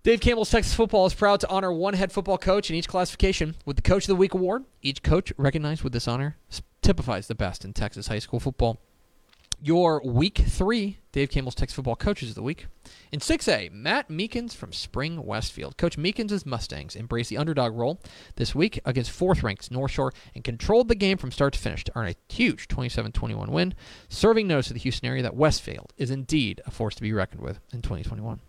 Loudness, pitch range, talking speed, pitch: -26 LUFS, 115-185 Hz, 205 wpm, 135 Hz